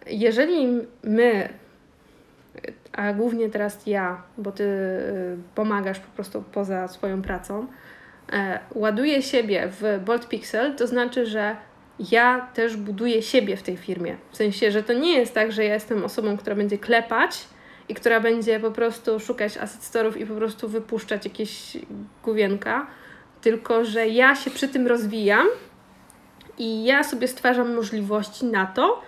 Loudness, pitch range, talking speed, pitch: -23 LUFS, 205-240 Hz, 145 wpm, 225 Hz